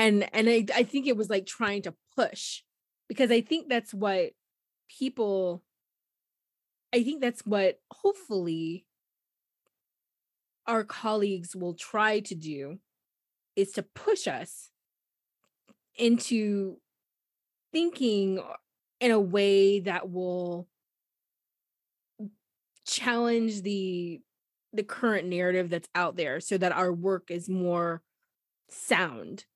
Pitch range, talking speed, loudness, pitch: 180-230 Hz, 110 wpm, -29 LUFS, 200 Hz